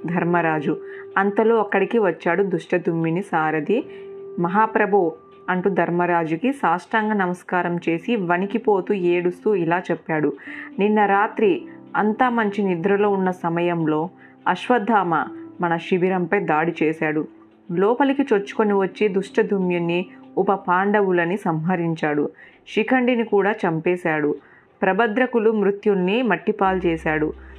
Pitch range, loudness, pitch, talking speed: 170-215 Hz, -21 LUFS, 190 Hz, 90 wpm